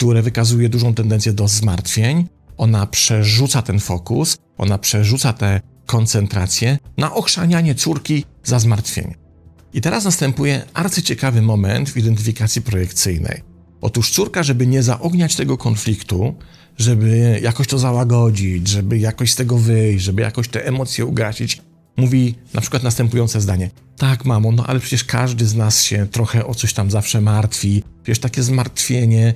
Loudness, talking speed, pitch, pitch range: -17 LUFS, 145 wpm, 115 Hz, 110-130 Hz